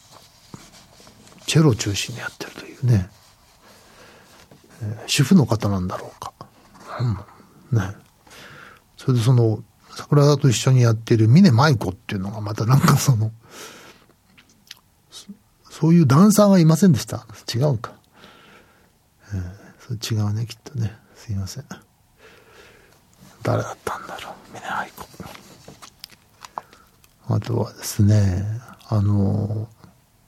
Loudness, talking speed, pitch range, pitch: -20 LUFS, 230 characters per minute, 105-140 Hz, 115 Hz